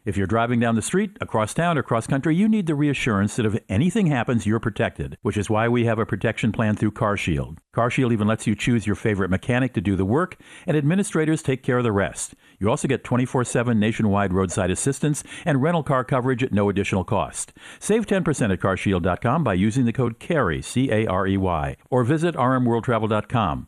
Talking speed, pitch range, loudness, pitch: 215 wpm, 105-135 Hz, -22 LUFS, 115 Hz